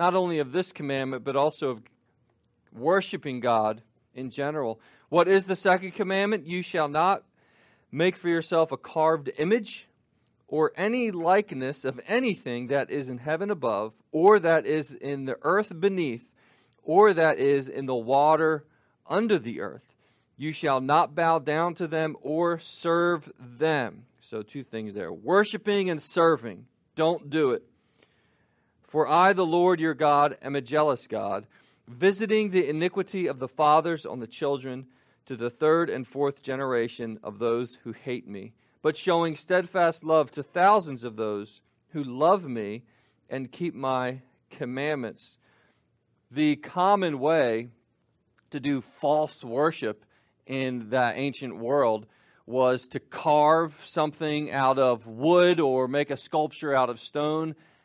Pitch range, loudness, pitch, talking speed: 130-170 Hz, -26 LUFS, 150 Hz, 145 wpm